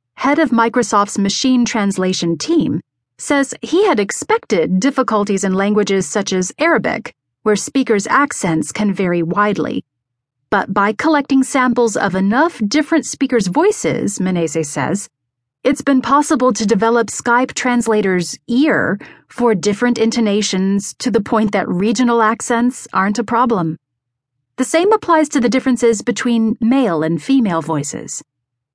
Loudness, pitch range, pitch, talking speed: -16 LUFS, 185-255 Hz, 220 Hz, 135 wpm